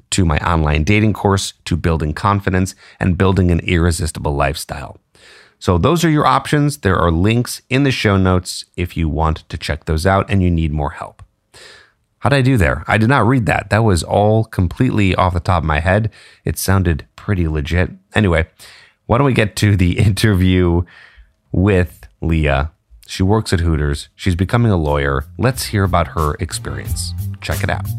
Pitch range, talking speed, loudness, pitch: 85-105 Hz, 185 wpm, -16 LUFS, 95 Hz